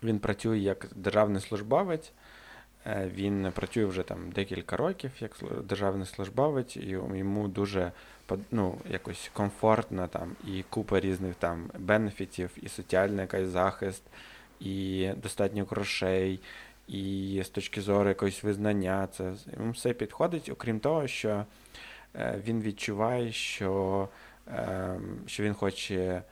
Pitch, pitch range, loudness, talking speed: 100 Hz, 95-110 Hz, -32 LUFS, 120 wpm